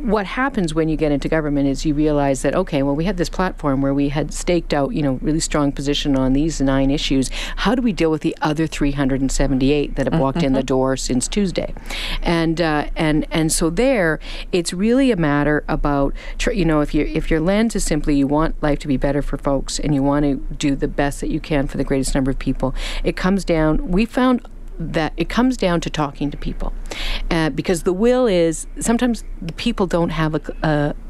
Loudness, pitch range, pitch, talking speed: -19 LUFS, 140-175 Hz, 155 Hz, 225 wpm